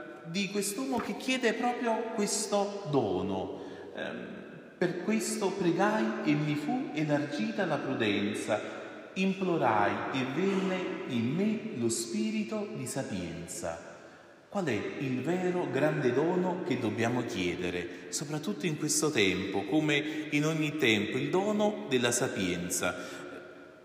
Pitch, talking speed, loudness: 150 Hz, 115 wpm, -31 LUFS